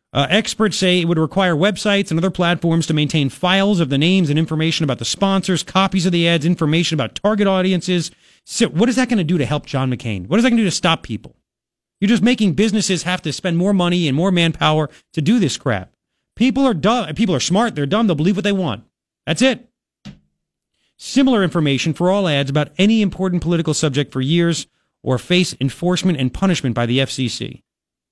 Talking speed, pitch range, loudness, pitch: 215 wpm, 150-195 Hz, -17 LUFS, 175 Hz